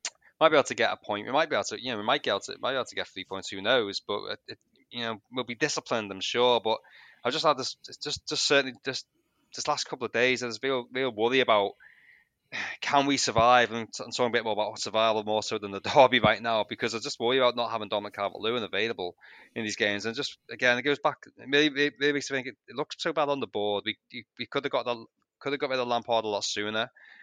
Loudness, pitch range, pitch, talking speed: -28 LUFS, 110-140 Hz, 120 Hz, 260 wpm